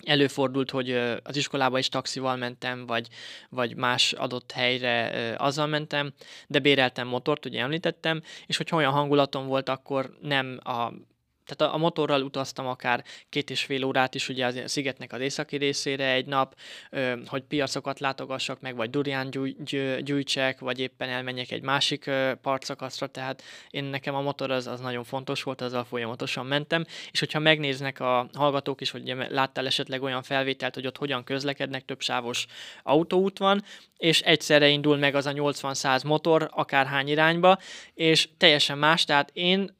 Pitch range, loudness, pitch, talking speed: 130-145 Hz, -26 LUFS, 135 Hz, 160 wpm